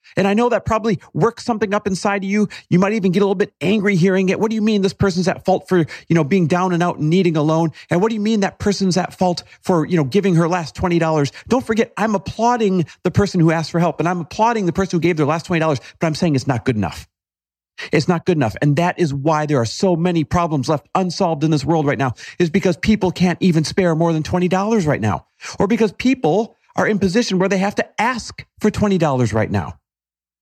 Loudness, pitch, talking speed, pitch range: -18 LUFS, 180 Hz, 255 wpm, 155-200 Hz